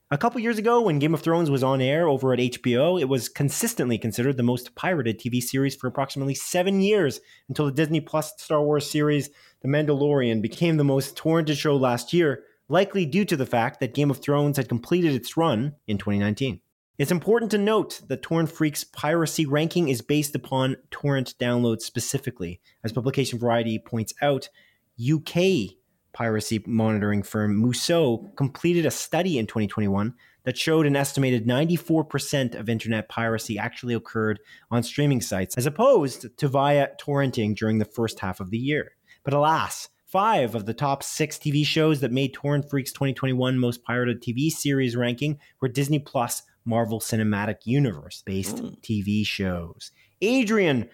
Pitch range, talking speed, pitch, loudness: 115-150 Hz, 165 wpm, 135 Hz, -24 LUFS